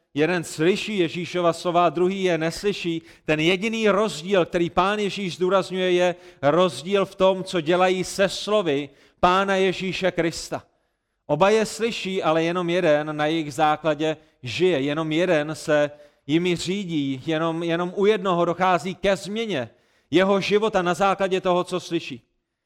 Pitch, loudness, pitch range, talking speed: 180 Hz, -22 LUFS, 160-190 Hz, 145 wpm